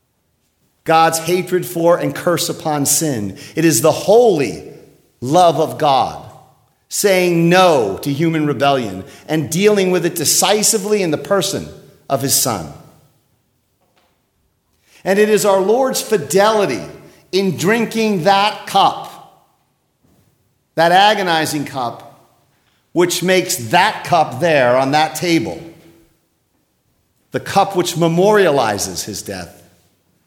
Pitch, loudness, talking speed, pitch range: 165 Hz, -15 LUFS, 115 wpm, 140-190 Hz